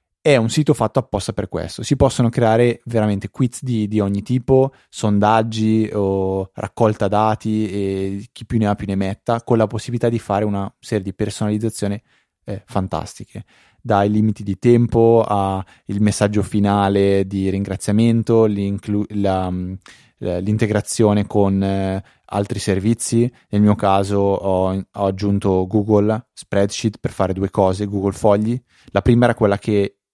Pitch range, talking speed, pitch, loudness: 100-115 Hz, 145 wpm, 105 Hz, -18 LUFS